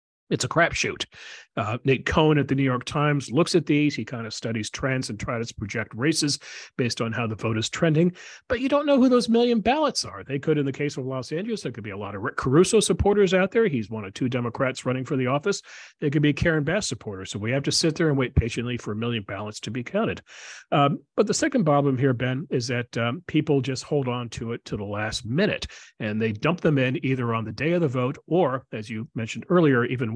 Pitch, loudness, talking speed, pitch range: 130 Hz, -24 LUFS, 255 wpm, 115-155 Hz